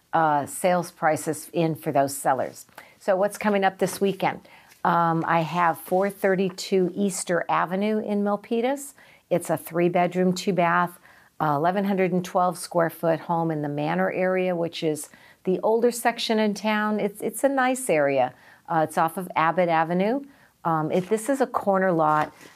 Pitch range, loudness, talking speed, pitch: 165-200 Hz, -24 LUFS, 155 wpm, 180 Hz